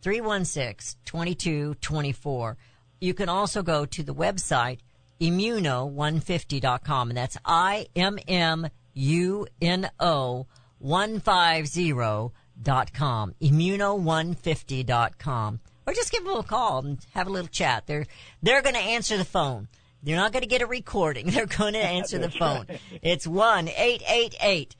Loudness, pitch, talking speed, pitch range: -26 LUFS, 160 Hz, 175 wpm, 130-190 Hz